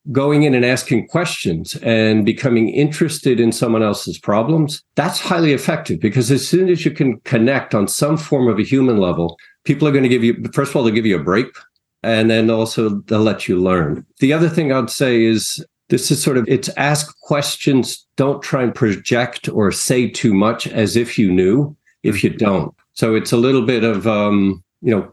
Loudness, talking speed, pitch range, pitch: -16 LUFS, 210 wpm, 110-145 Hz, 125 Hz